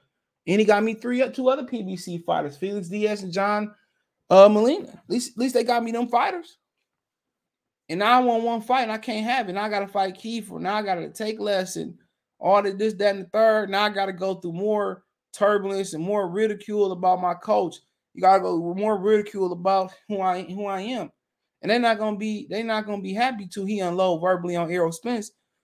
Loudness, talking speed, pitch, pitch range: -23 LUFS, 225 wpm, 205 Hz, 190-225 Hz